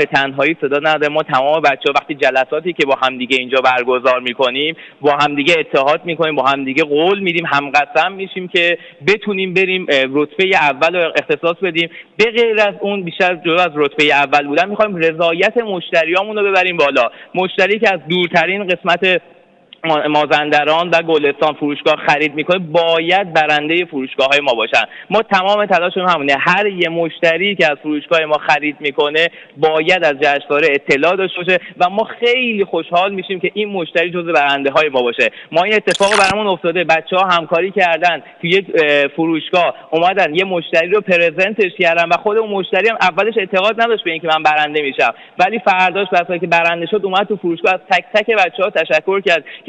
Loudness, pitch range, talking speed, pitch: -14 LUFS, 150-190 Hz, 175 wpm, 170 Hz